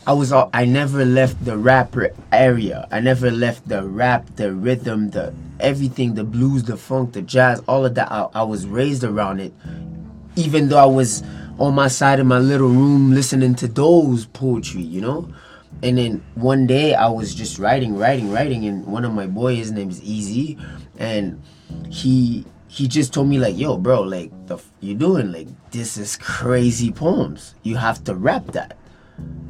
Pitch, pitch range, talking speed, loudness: 125 Hz, 110-135 Hz, 190 wpm, -18 LUFS